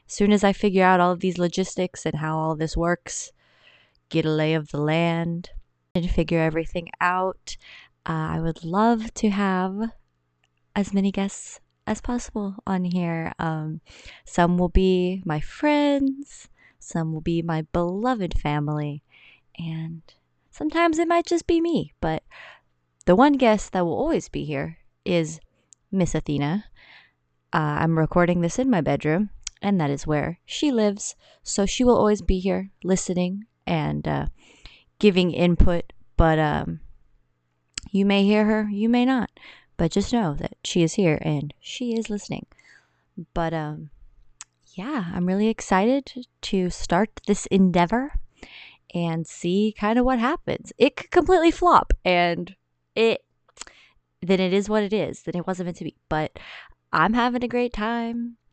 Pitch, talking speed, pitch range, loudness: 180 Hz, 155 wpm, 160-210 Hz, -23 LUFS